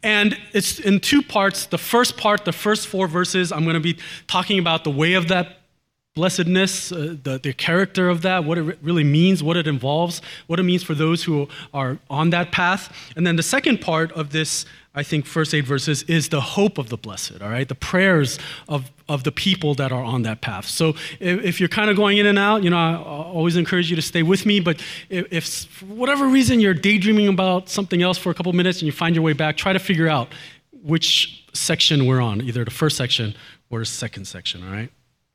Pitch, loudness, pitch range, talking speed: 165 Hz, -20 LUFS, 150-185 Hz, 235 wpm